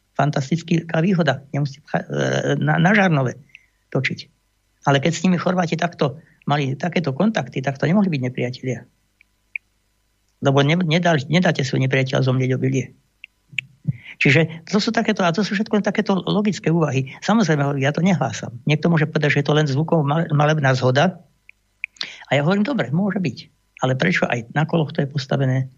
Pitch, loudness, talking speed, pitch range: 150 Hz, -20 LUFS, 150 wpm, 130-175 Hz